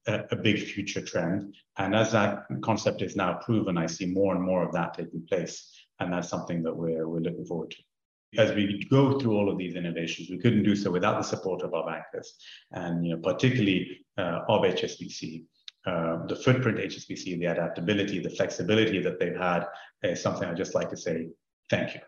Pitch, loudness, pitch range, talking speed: 95 Hz, -28 LUFS, 85-105 Hz, 205 wpm